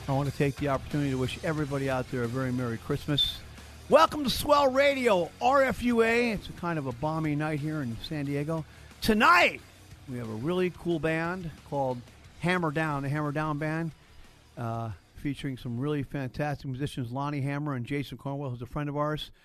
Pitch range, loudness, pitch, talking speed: 130-160 Hz, -28 LUFS, 145 Hz, 190 wpm